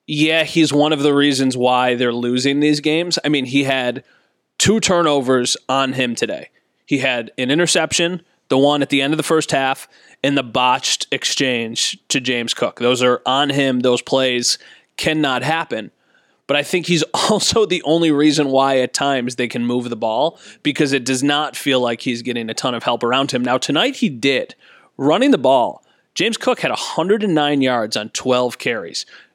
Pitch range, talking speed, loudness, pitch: 125-150 Hz, 190 wpm, -17 LUFS, 135 Hz